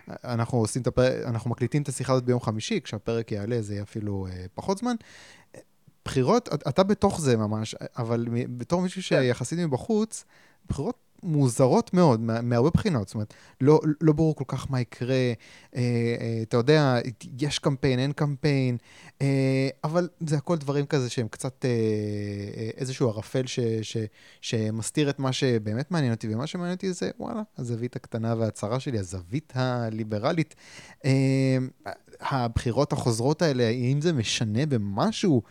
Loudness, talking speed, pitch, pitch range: -26 LUFS, 145 wpm, 130 Hz, 115-150 Hz